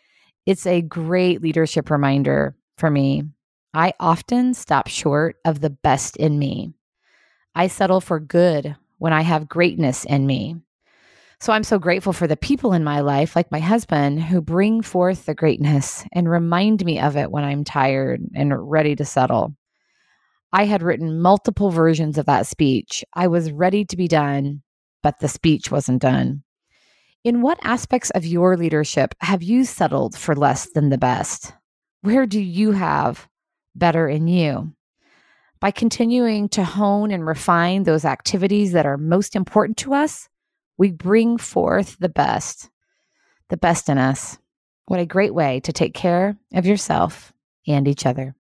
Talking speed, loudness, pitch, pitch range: 160 wpm, -19 LUFS, 170 Hz, 150-200 Hz